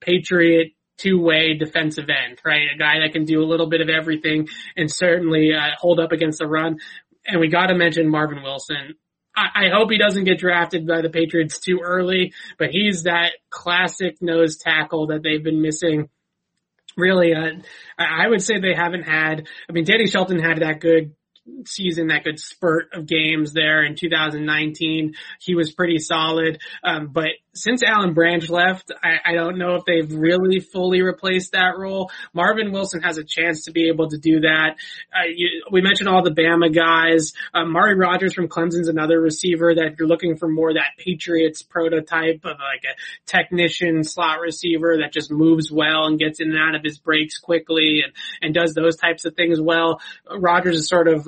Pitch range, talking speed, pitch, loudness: 160-180 Hz, 190 wpm, 165 Hz, -19 LUFS